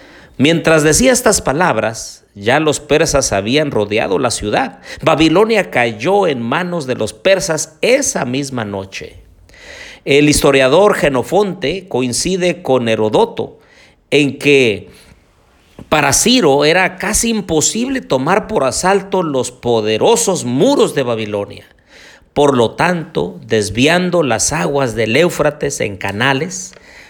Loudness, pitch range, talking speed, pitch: -13 LUFS, 115-175 Hz, 115 wpm, 145 Hz